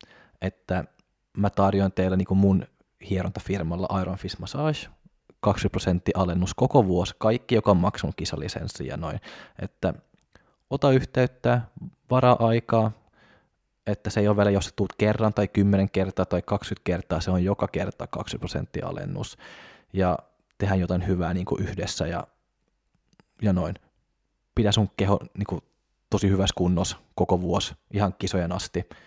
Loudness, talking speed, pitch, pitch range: -26 LUFS, 145 wpm, 95 Hz, 90-105 Hz